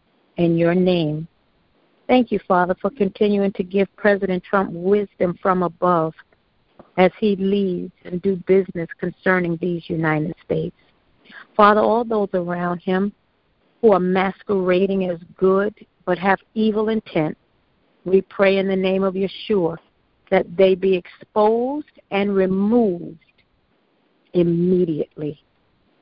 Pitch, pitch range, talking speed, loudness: 190 Hz, 175-200 Hz, 120 wpm, -20 LUFS